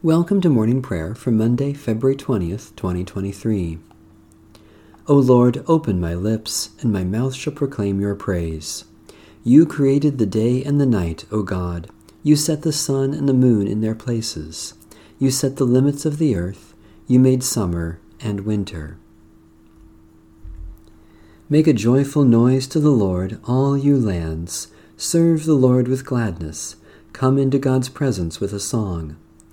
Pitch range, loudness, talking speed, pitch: 85-130 Hz, -19 LUFS, 150 wpm, 110 Hz